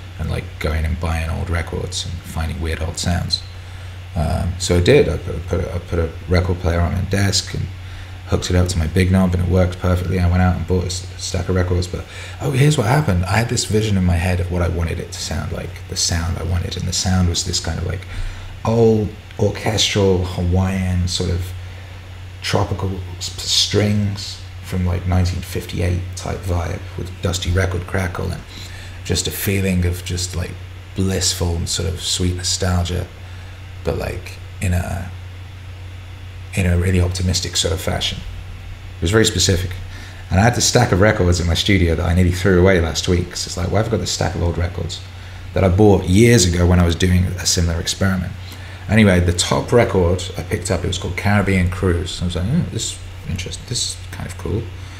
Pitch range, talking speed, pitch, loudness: 90-95 Hz, 210 wpm, 90 Hz, -19 LUFS